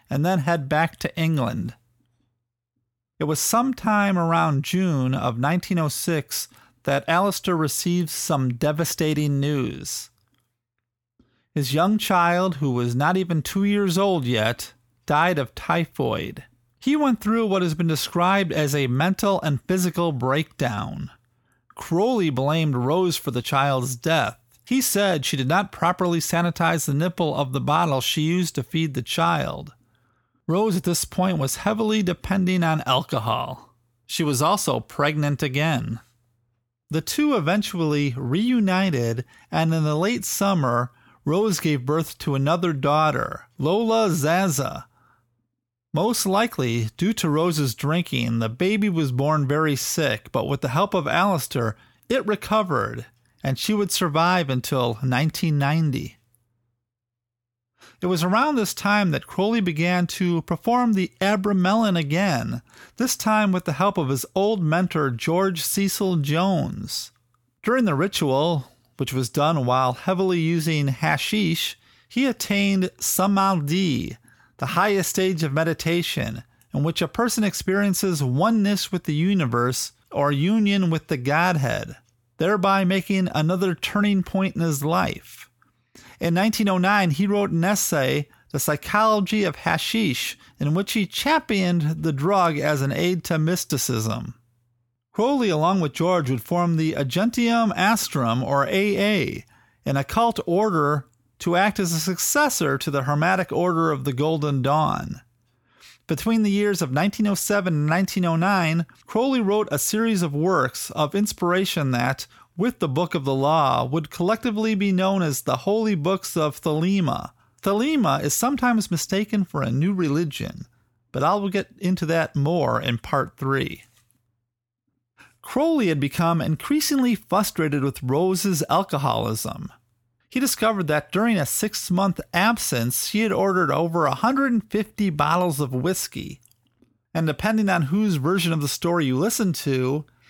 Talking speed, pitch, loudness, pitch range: 140 wpm, 165 Hz, -22 LUFS, 135-195 Hz